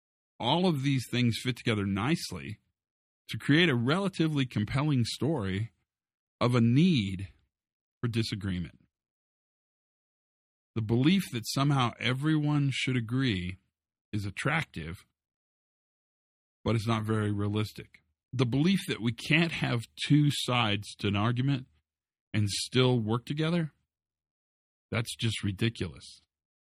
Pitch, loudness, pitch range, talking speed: 115 Hz, -29 LUFS, 95-135 Hz, 115 wpm